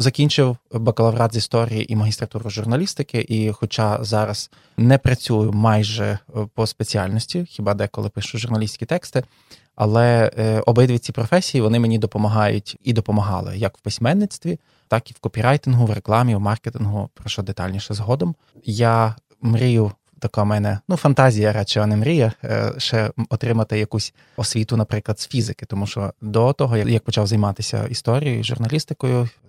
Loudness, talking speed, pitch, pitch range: -20 LUFS, 140 wpm, 115 Hz, 105-125 Hz